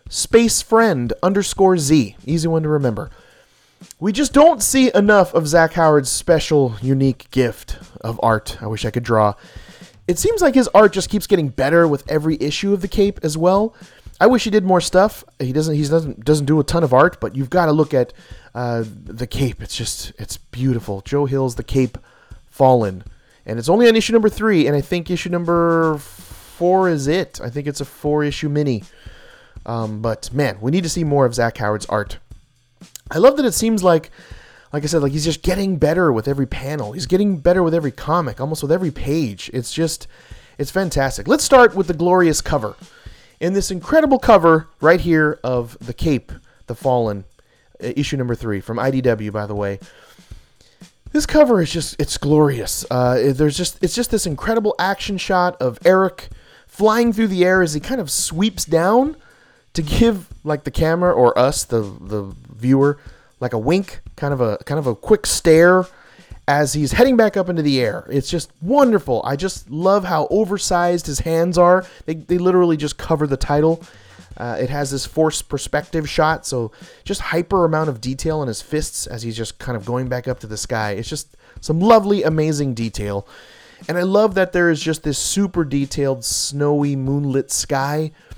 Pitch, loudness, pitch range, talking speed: 150 Hz, -18 LUFS, 125-180 Hz, 195 wpm